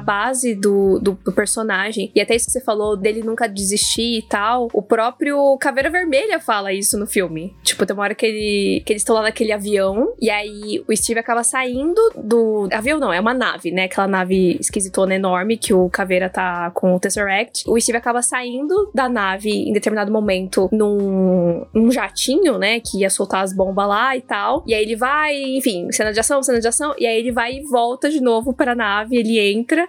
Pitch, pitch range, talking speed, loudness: 220 Hz, 200-250 Hz, 210 wpm, -18 LUFS